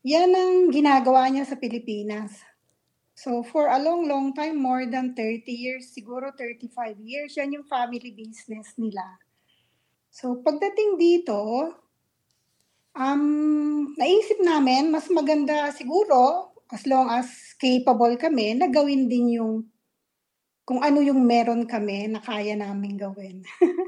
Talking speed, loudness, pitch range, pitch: 130 wpm, -23 LUFS, 235-300 Hz, 255 Hz